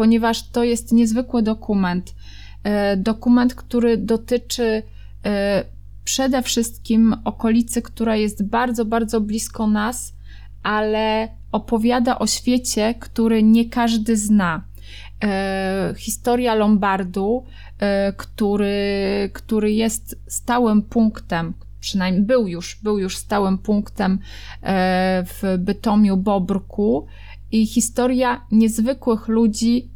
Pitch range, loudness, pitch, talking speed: 195-230 Hz, -20 LUFS, 215 Hz, 90 wpm